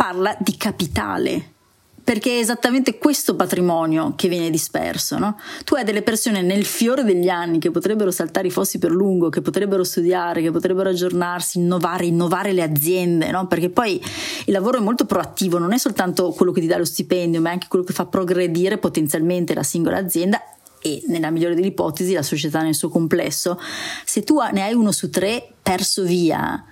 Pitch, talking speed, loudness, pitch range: 185 Hz, 190 wpm, -20 LUFS, 175-205 Hz